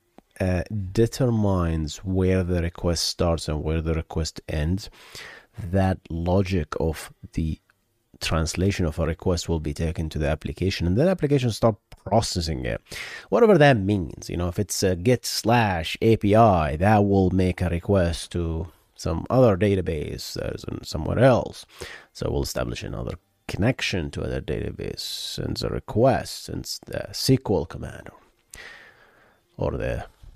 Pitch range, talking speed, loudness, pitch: 85-110 Hz, 140 wpm, -24 LUFS, 95 Hz